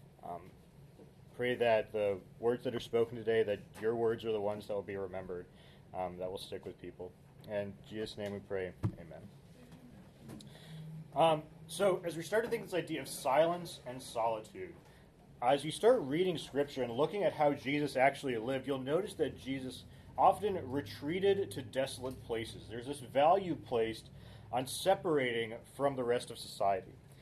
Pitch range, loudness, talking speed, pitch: 110-150 Hz, -35 LUFS, 170 wpm, 130 Hz